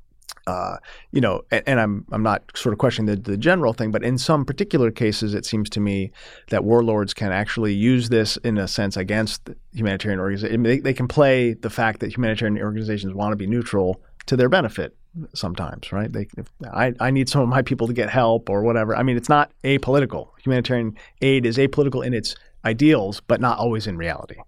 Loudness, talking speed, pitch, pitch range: -21 LUFS, 215 wpm, 115 Hz, 105-125 Hz